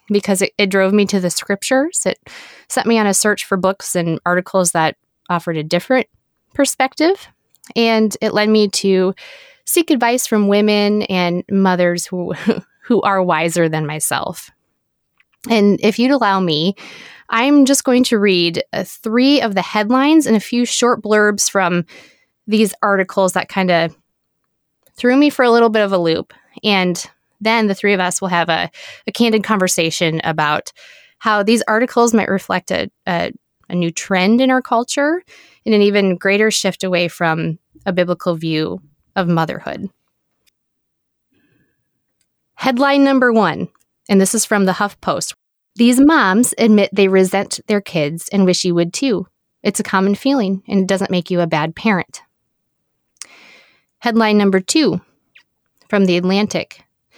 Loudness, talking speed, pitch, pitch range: -15 LUFS, 160 wpm, 200 Hz, 180-230 Hz